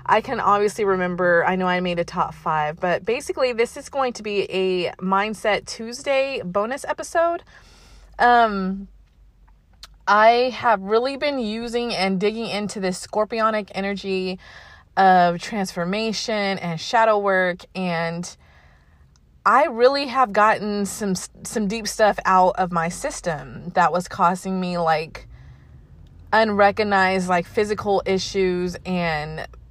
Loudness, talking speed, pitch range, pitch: -21 LUFS, 125 wpm, 175-220 Hz, 190 Hz